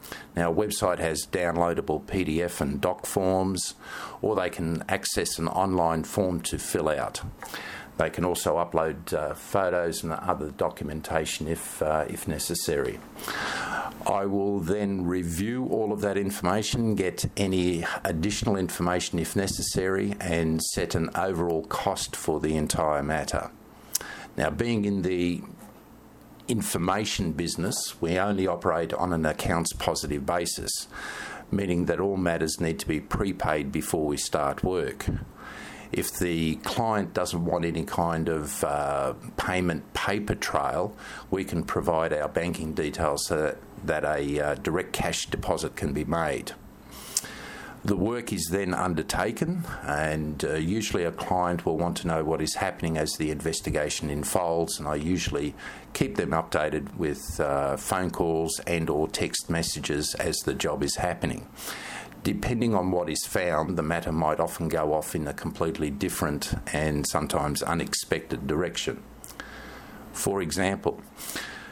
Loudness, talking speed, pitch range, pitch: -28 LUFS, 140 wpm, 80-95 Hz, 85 Hz